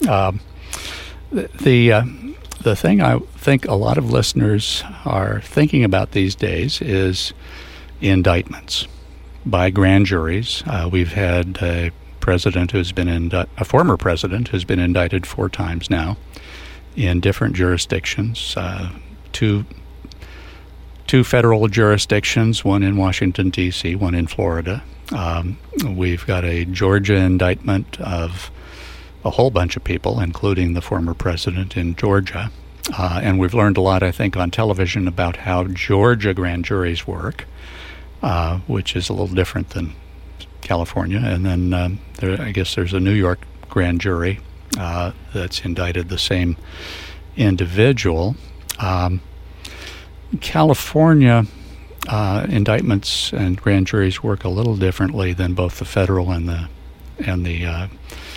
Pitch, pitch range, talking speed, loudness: 90 Hz, 85-100 Hz, 140 wpm, -19 LUFS